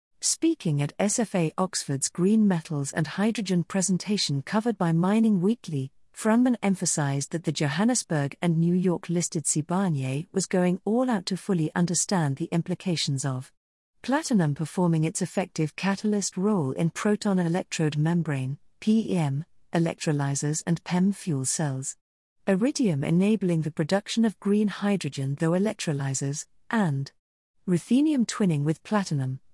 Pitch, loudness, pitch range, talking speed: 175 Hz, -26 LUFS, 150-200 Hz, 125 wpm